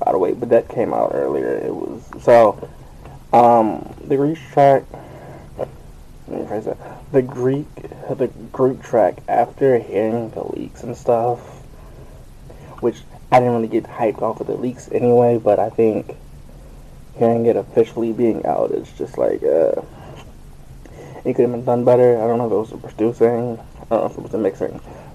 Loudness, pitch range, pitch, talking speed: -18 LUFS, 115-140 Hz, 125 Hz, 180 wpm